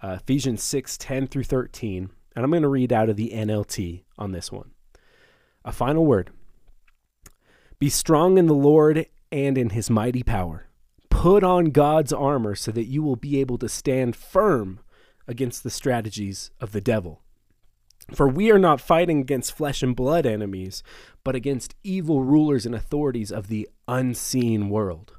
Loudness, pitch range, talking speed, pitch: -22 LUFS, 110-145 Hz, 165 wpm, 125 Hz